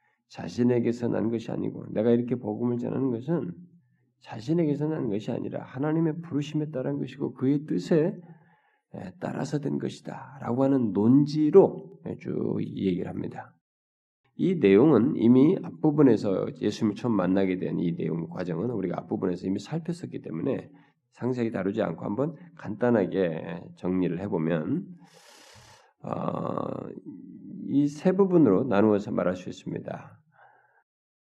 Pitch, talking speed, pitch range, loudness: 130 Hz, 300 characters per minute, 110-155 Hz, -26 LUFS